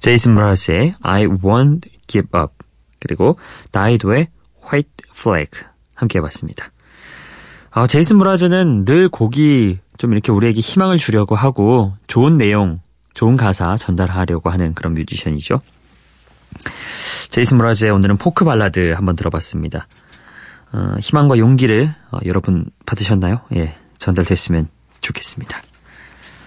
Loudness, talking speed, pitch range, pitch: -15 LUFS, 310 characters per minute, 90-130 Hz, 105 Hz